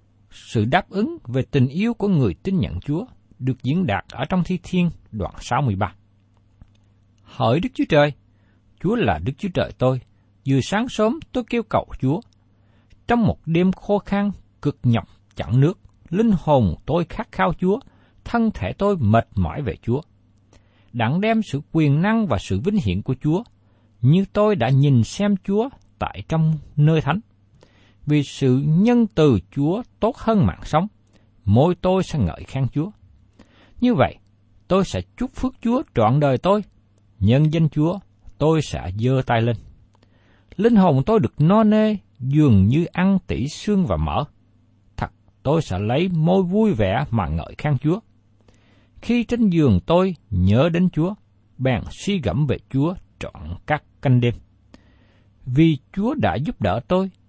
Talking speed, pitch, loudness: 165 wpm, 135 Hz, -21 LUFS